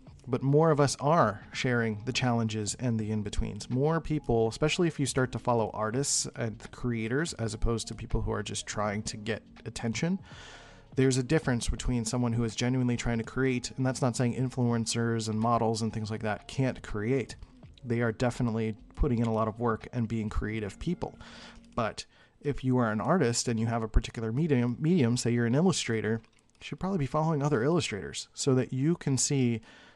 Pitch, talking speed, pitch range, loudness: 120 Hz, 200 wpm, 110-130 Hz, -30 LUFS